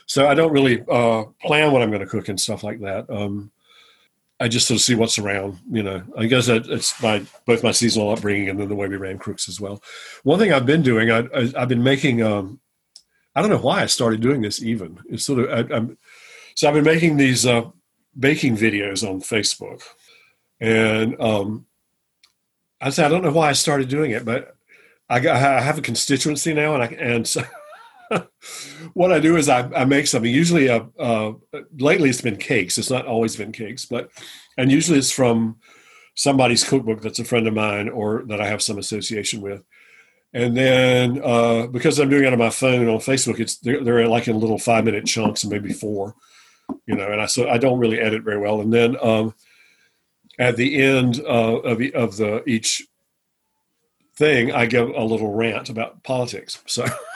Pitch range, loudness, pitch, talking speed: 110-130 Hz, -19 LUFS, 115 Hz, 205 wpm